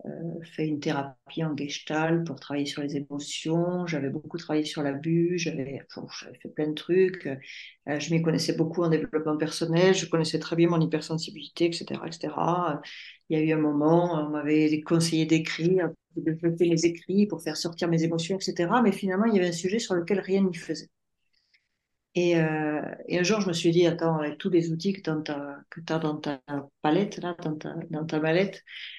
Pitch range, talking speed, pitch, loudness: 155-175 Hz, 205 wpm, 160 Hz, -27 LUFS